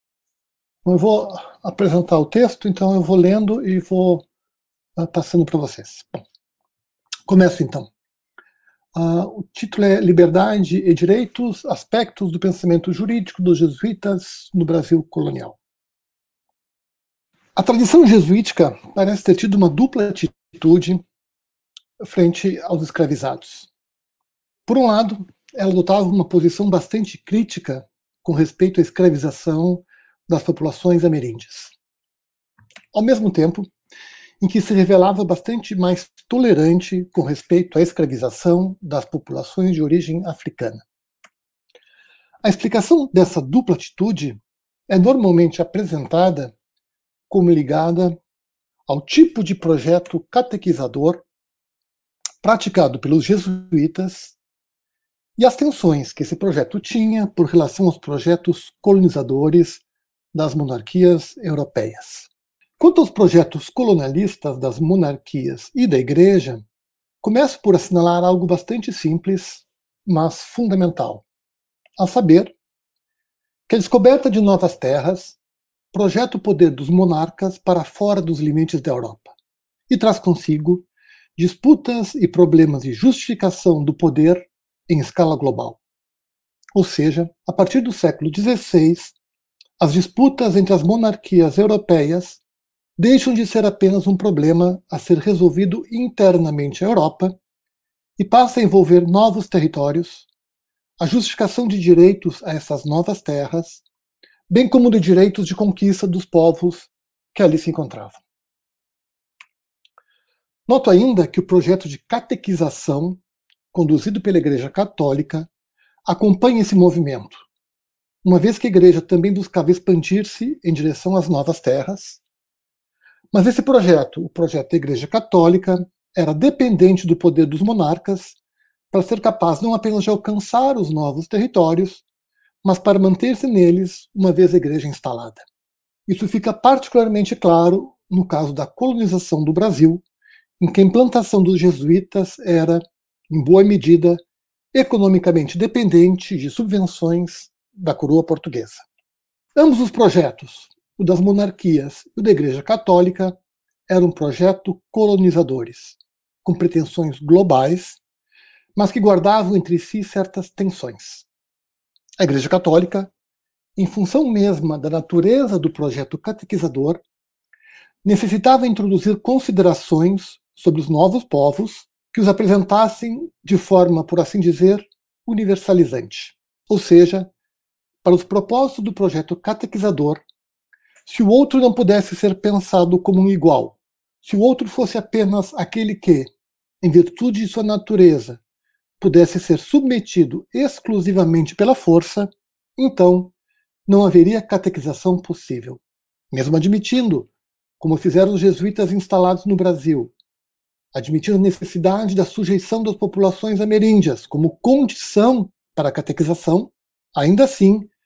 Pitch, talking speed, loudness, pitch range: 185 Hz, 120 wpm, -16 LUFS, 170-210 Hz